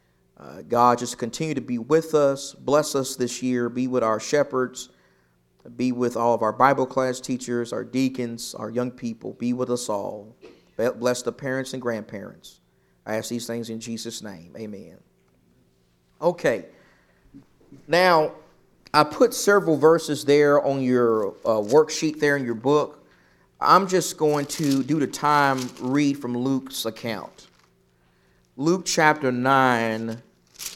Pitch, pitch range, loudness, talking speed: 125 Hz, 115-145 Hz, -23 LUFS, 145 wpm